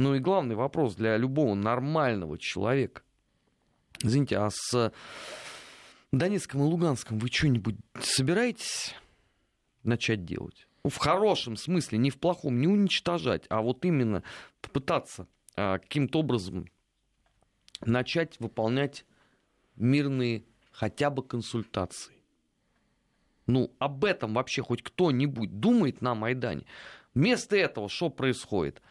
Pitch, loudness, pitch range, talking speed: 125 Hz, -29 LUFS, 115-145 Hz, 110 wpm